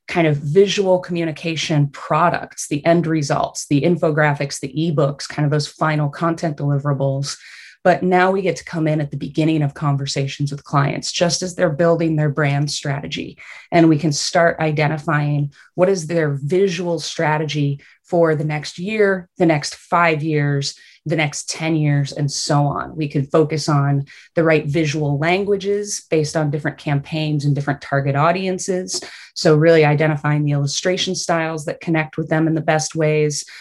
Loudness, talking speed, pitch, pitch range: -19 LUFS, 170 wpm, 155 Hz, 145-170 Hz